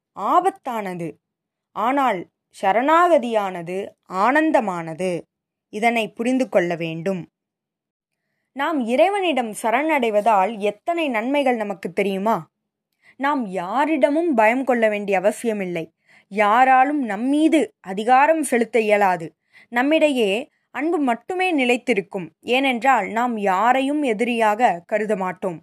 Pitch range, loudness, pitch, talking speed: 200-270 Hz, -20 LUFS, 230 Hz, 85 wpm